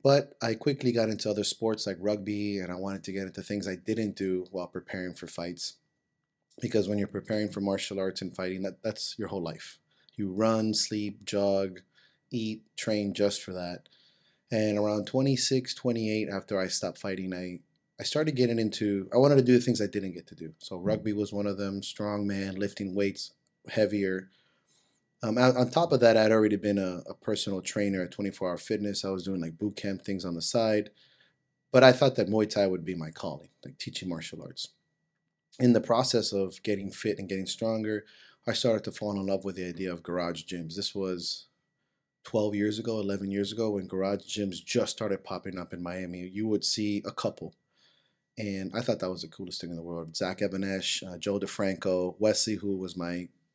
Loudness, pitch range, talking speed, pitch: -30 LUFS, 95-110 Hz, 205 wpm, 100 Hz